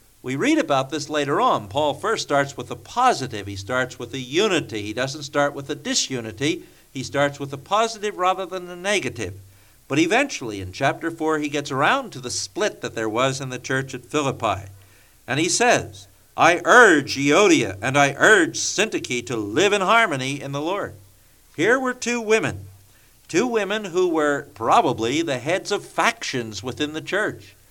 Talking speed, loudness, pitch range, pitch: 180 wpm, -21 LUFS, 115-165 Hz, 140 Hz